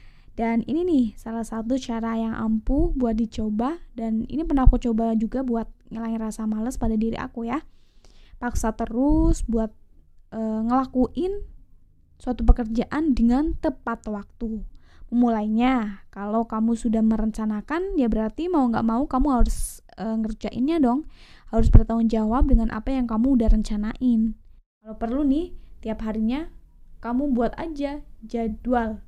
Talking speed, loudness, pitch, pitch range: 140 wpm, -24 LUFS, 230 Hz, 220-260 Hz